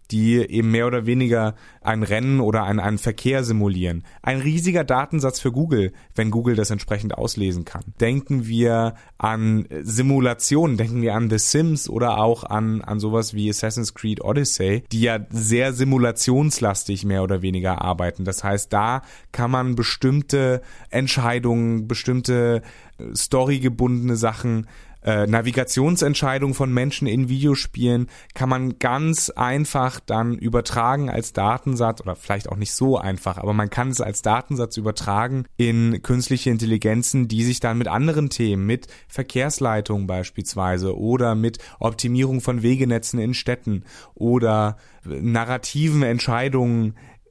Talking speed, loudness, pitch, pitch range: 135 wpm, -21 LUFS, 115 Hz, 110-130 Hz